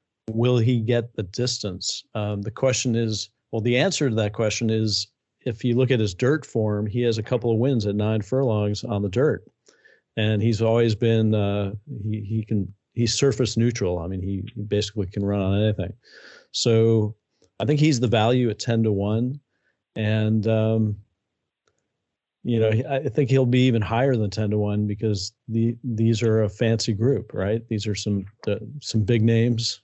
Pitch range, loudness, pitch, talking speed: 105-120 Hz, -23 LUFS, 110 Hz, 185 wpm